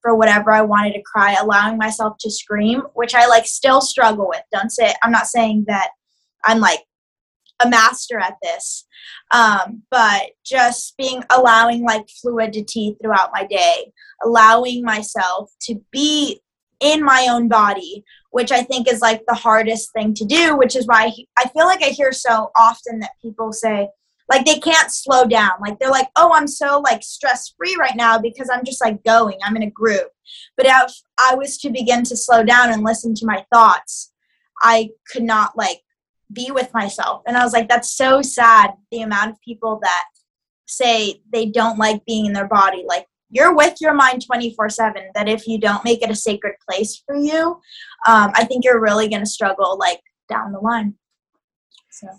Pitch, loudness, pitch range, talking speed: 230 Hz, -15 LUFS, 215-255 Hz, 190 wpm